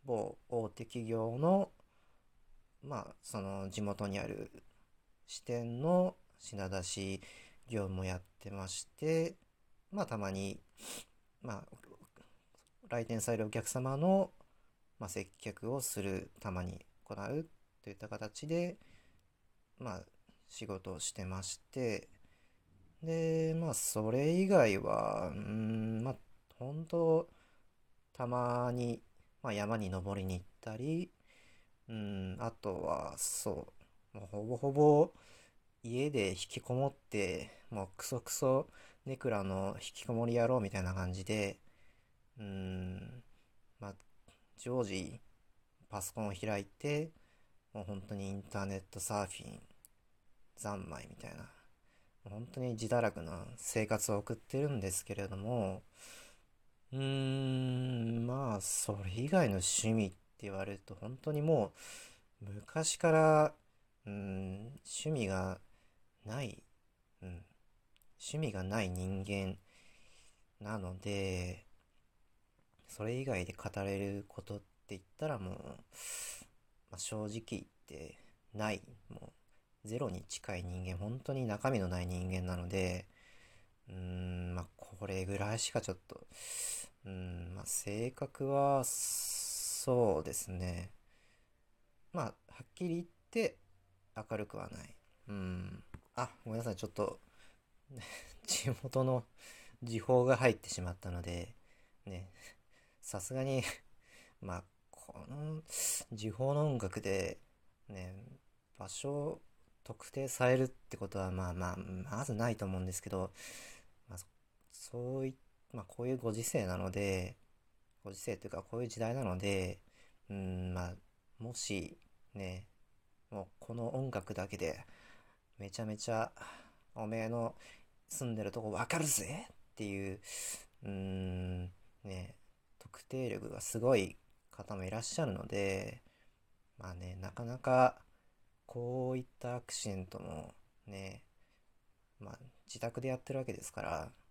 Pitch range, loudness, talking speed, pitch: 95-120 Hz, -38 LUFS, 220 characters per minute, 105 Hz